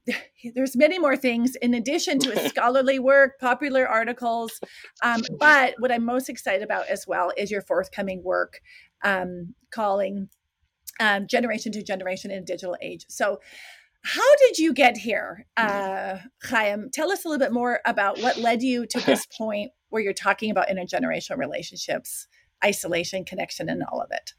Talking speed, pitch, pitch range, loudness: 165 wpm, 230 Hz, 200-265 Hz, -23 LUFS